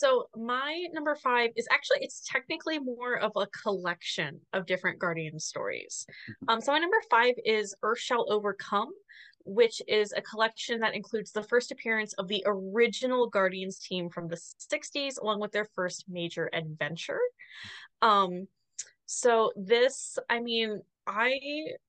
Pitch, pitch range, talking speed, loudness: 225 Hz, 195-285 Hz, 150 wpm, -30 LUFS